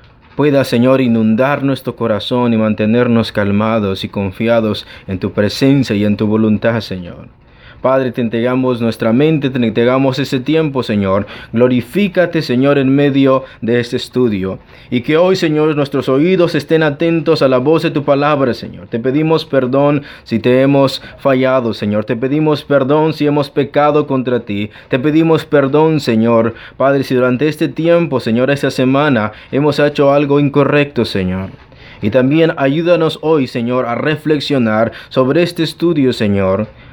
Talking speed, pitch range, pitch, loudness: 155 wpm, 115-145 Hz, 130 Hz, -13 LUFS